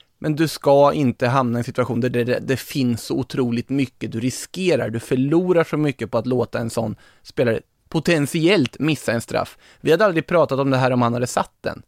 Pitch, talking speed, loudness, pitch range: 130 Hz, 215 wpm, -20 LUFS, 120-155 Hz